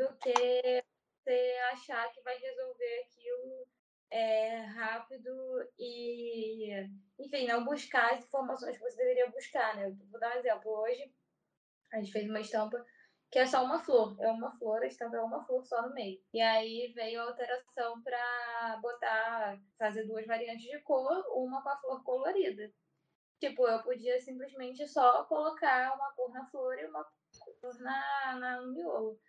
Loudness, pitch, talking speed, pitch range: -35 LUFS, 250 Hz, 170 wpm, 225-275 Hz